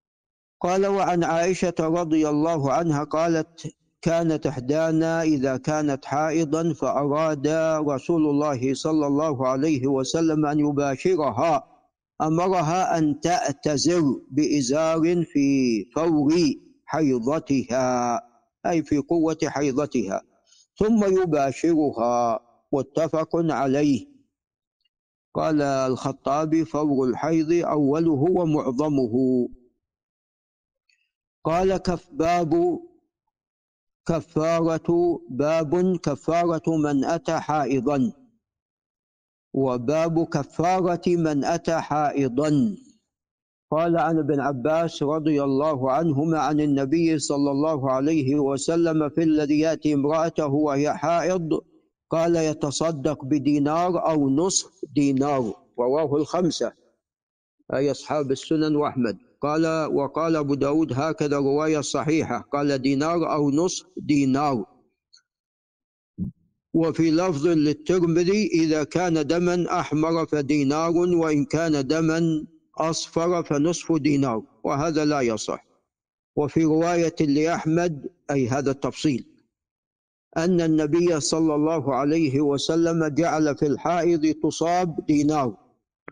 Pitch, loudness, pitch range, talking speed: 155 Hz, -23 LUFS, 145-165 Hz, 95 wpm